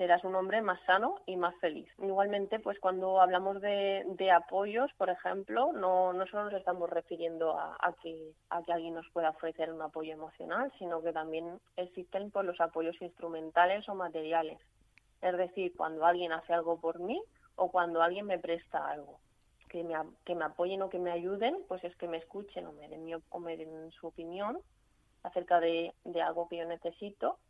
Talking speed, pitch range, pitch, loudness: 195 wpm, 165-190 Hz, 175 Hz, -34 LUFS